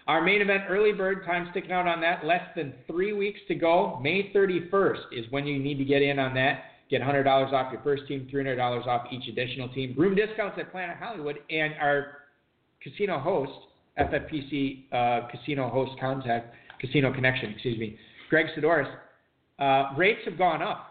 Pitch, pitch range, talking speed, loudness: 145 Hz, 130-175 Hz, 180 wpm, -27 LUFS